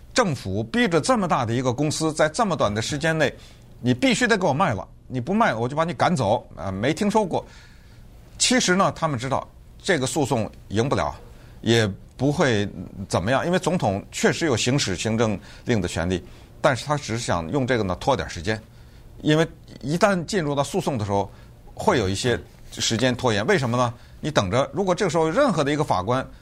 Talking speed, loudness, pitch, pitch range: 300 characters per minute, -23 LUFS, 130 Hz, 110-160 Hz